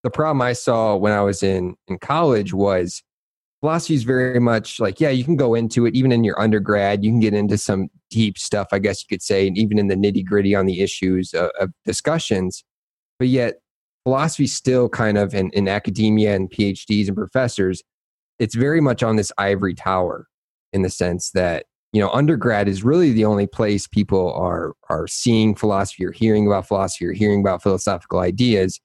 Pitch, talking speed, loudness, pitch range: 105 Hz, 200 wpm, -19 LUFS, 95-120 Hz